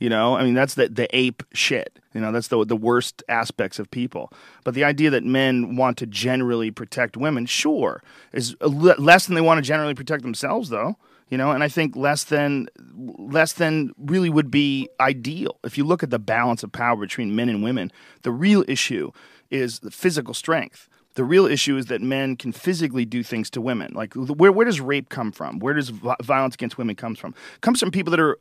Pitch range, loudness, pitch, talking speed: 120-155 Hz, -21 LUFS, 135 Hz, 220 wpm